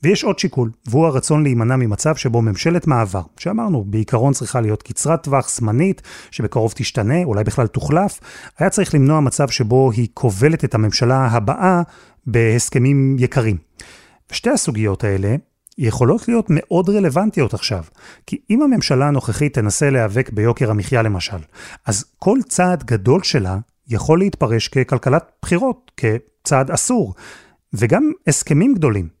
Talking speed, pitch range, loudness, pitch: 135 wpm, 115-165 Hz, -17 LUFS, 130 Hz